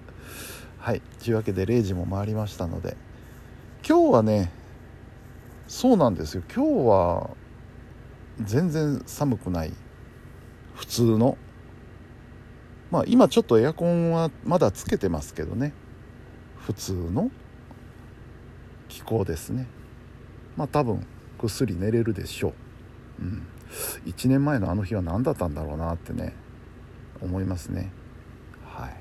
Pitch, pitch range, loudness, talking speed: 115 Hz, 95-125 Hz, -25 LUFS, 230 characters per minute